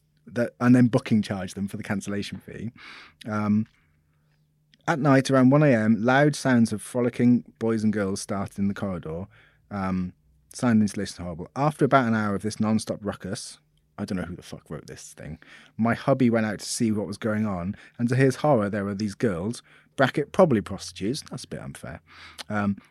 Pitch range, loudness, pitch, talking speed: 100-120 Hz, -24 LUFS, 105 Hz, 200 wpm